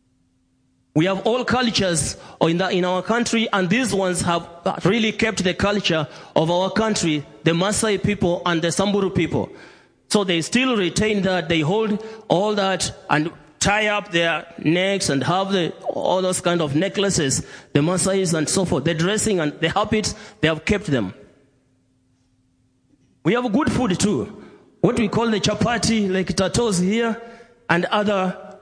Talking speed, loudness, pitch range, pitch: 160 wpm, -20 LUFS, 160-210 Hz, 185 Hz